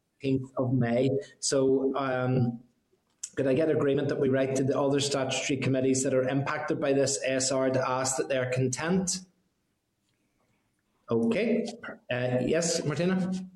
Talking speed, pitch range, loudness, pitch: 140 wpm, 130-150 Hz, -28 LUFS, 135 Hz